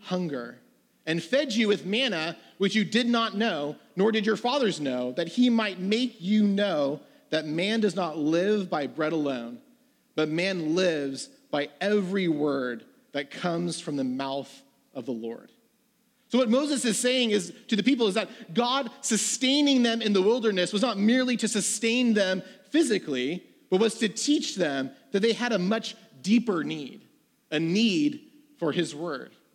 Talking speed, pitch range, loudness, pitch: 175 wpm, 165-235 Hz, -26 LUFS, 210 Hz